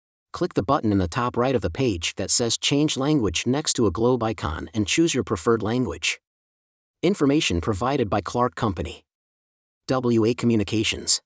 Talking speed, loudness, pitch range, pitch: 165 wpm, -23 LUFS, 90-125 Hz, 115 Hz